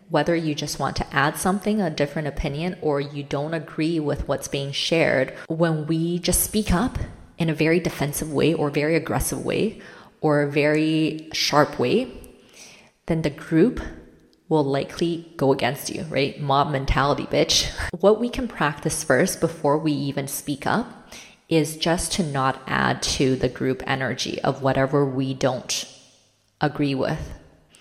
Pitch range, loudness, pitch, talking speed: 135-160 Hz, -23 LUFS, 150 Hz, 160 wpm